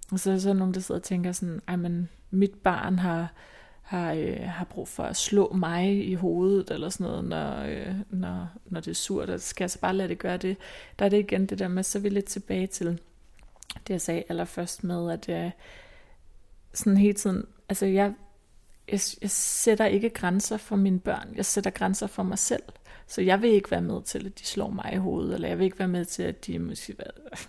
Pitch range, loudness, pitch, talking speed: 180-205 Hz, -28 LUFS, 190 Hz, 235 wpm